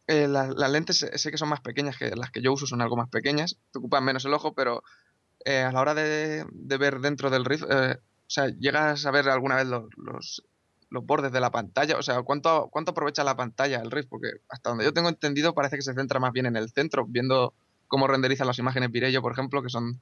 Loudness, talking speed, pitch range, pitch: -26 LUFS, 250 wpm, 125-145 Hz, 135 Hz